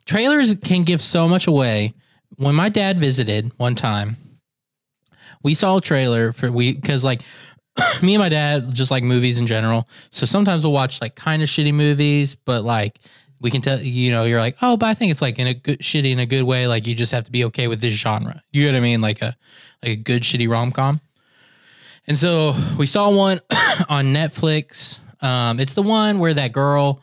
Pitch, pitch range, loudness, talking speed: 135 Hz, 120-155 Hz, -18 LUFS, 215 wpm